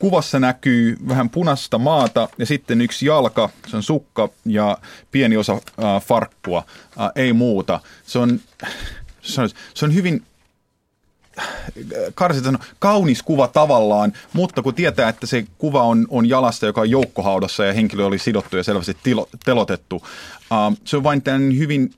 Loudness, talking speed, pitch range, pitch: -18 LUFS, 155 wpm, 115-150 Hz, 125 Hz